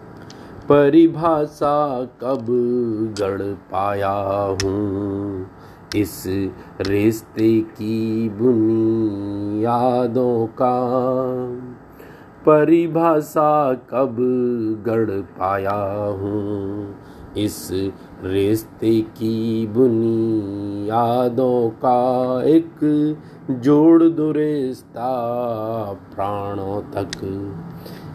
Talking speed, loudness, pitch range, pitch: 60 wpm, -19 LUFS, 100-130 Hz, 115 Hz